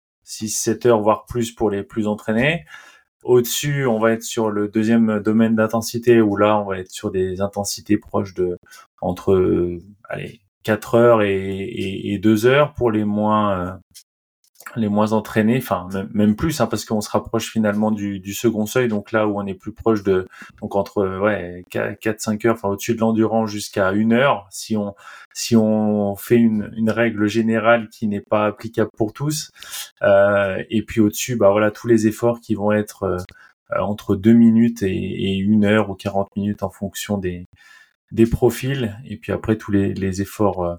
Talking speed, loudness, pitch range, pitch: 195 wpm, -19 LUFS, 100-115 Hz, 105 Hz